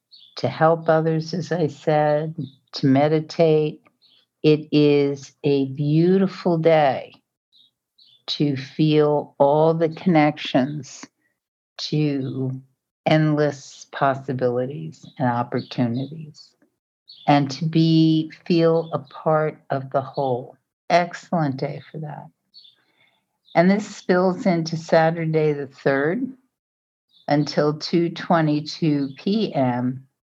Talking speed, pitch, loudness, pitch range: 90 wpm, 150 Hz, -21 LUFS, 140-160 Hz